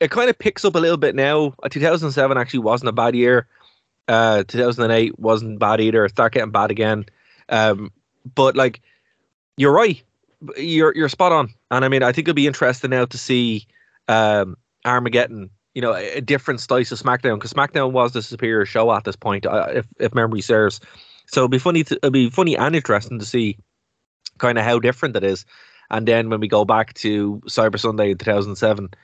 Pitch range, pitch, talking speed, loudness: 110-135 Hz, 120 Hz, 215 wpm, -18 LUFS